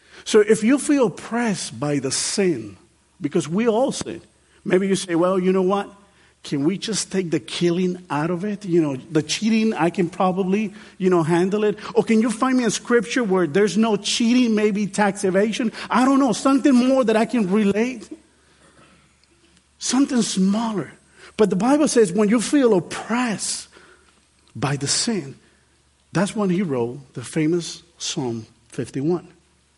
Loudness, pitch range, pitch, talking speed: -20 LUFS, 170-225 Hz, 200 Hz, 165 wpm